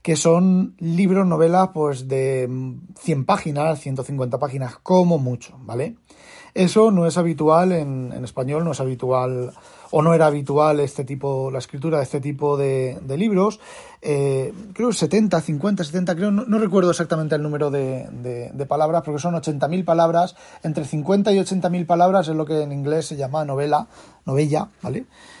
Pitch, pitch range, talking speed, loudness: 155 Hz, 140-180 Hz, 170 wpm, -20 LUFS